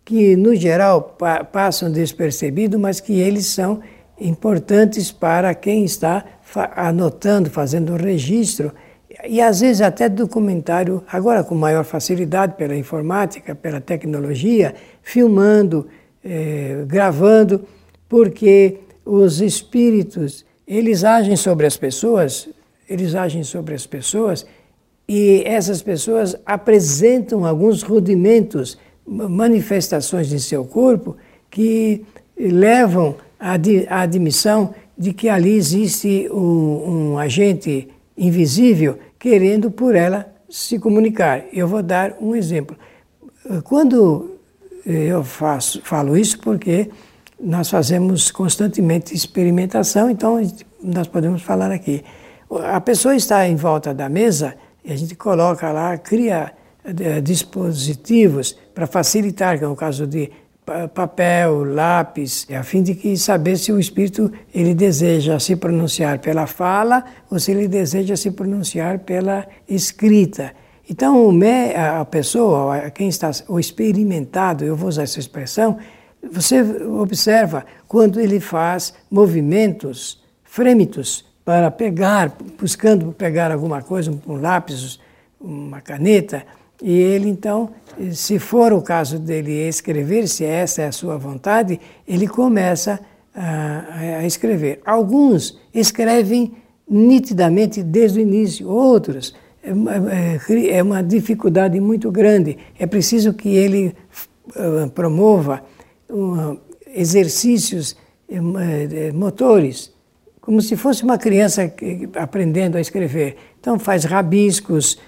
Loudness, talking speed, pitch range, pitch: -17 LUFS, 115 wpm, 160-210 Hz, 185 Hz